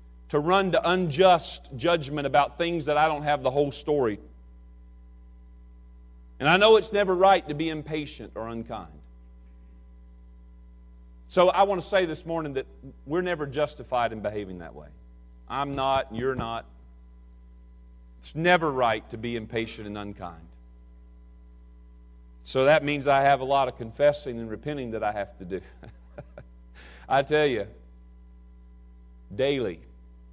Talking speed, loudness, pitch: 140 wpm, -25 LUFS, 105 Hz